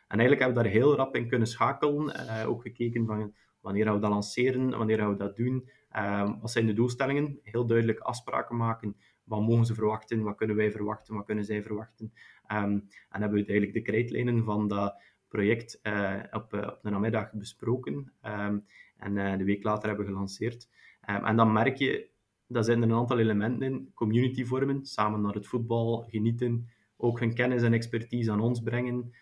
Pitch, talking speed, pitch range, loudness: 115 Hz, 195 wpm, 105-120 Hz, -29 LUFS